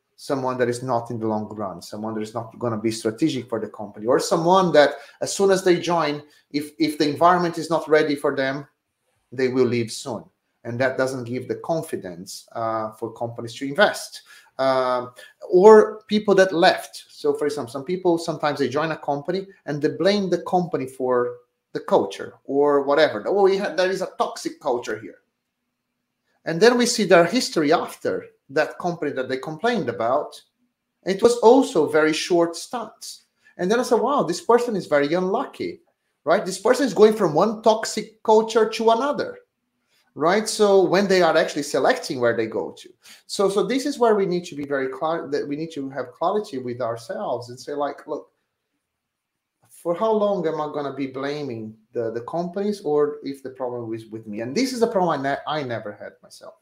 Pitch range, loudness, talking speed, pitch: 130-200 Hz, -22 LUFS, 200 wpm, 155 Hz